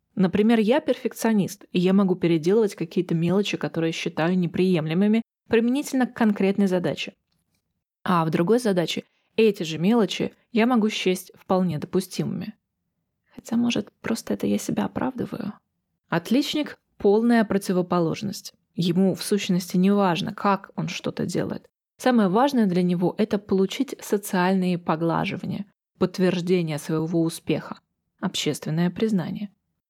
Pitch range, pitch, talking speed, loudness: 180-220 Hz, 195 Hz, 120 wpm, -24 LUFS